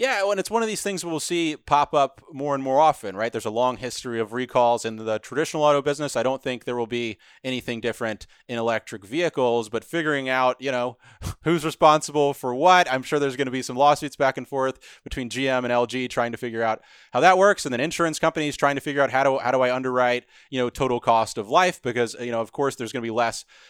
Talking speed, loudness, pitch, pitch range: 250 wpm, -23 LUFS, 130 Hz, 120-145 Hz